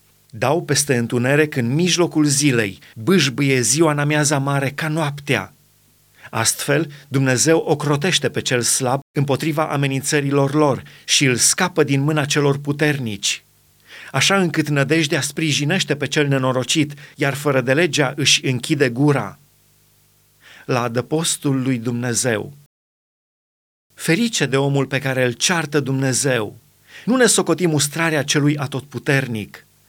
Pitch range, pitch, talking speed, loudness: 130-155 Hz, 145 Hz, 120 wpm, -18 LUFS